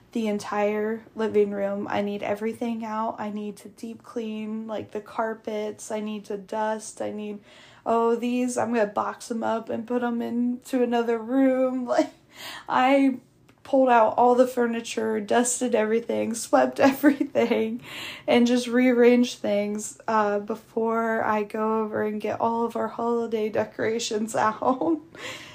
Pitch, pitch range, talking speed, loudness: 225 Hz, 215-240 Hz, 145 wpm, -25 LUFS